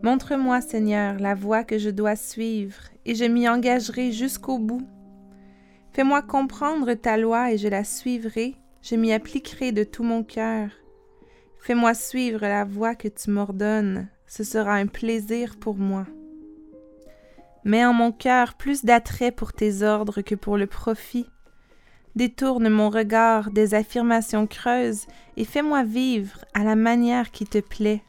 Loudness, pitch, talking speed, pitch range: -23 LUFS, 225 Hz, 150 wpm, 210-245 Hz